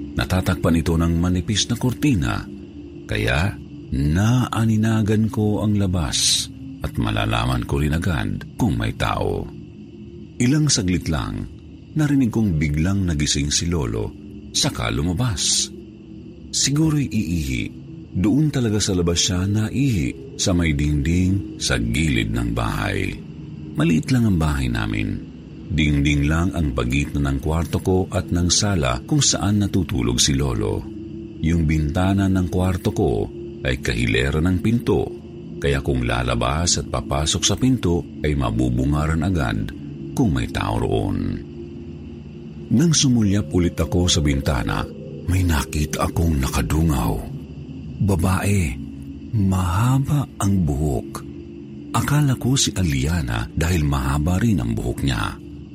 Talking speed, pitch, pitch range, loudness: 125 wpm, 90 Hz, 75-105 Hz, -21 LUFS